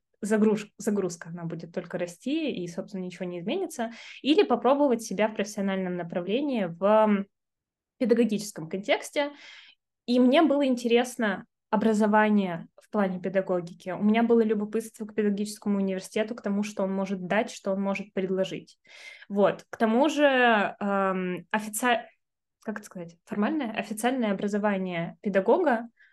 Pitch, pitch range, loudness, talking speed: 210 Hz, 190-235 Hz, -27 LUFS, 135 wpm